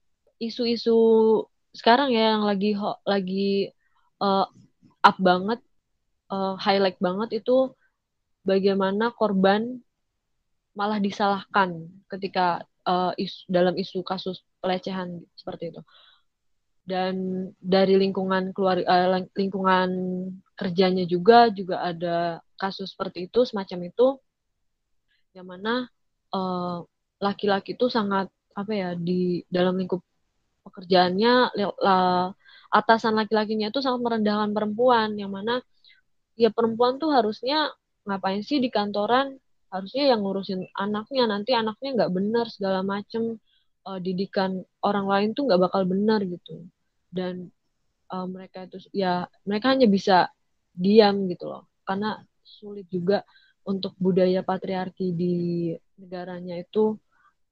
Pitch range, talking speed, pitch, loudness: 185-220 Hz, 115 wpm, 195 Hz, -24 LUFS